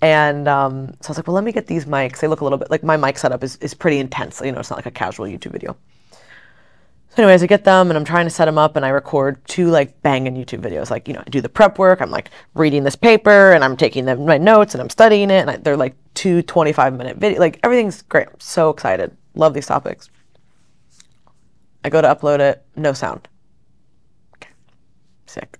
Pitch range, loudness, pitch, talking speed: 135-180 Hz, -15 LUFS, 155 Hz, 240 wpm